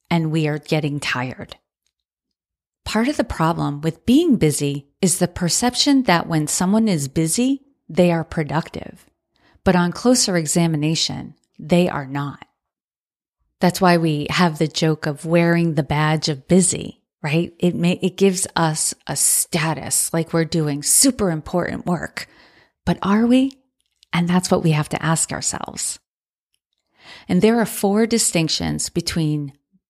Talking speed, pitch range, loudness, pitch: 145 wpm, 155-190 Hz, -19 LUFS, 170 Hz